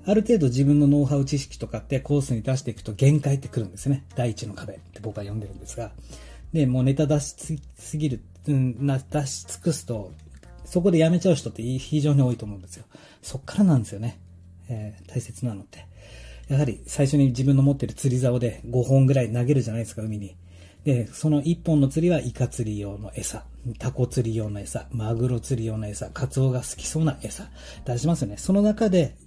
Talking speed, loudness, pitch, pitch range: 395 characters per minute, -24 LUFS, 125 Hz, 110-145 Hz